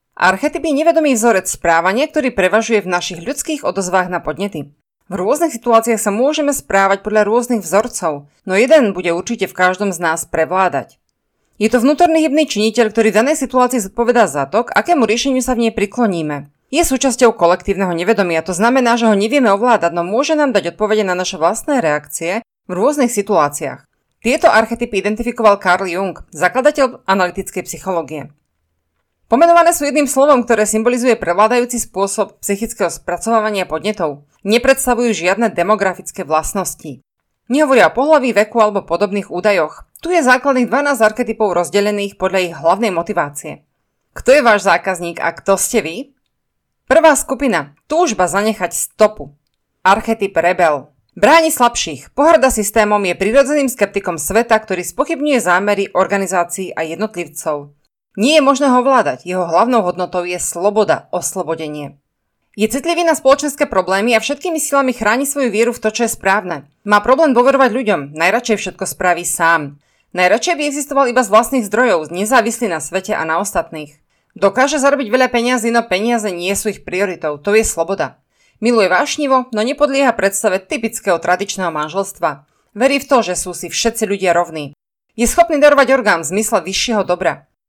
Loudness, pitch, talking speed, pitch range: -15 LUFS, 210 Hz, 155 wpm, 180-250 Hz